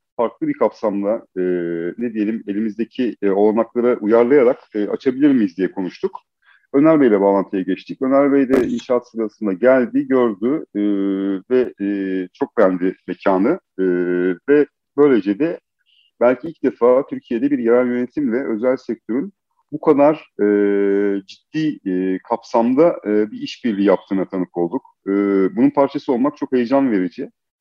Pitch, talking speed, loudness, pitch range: 115 Hz, 140 wpm, -18 LUFS, 100-140 Hz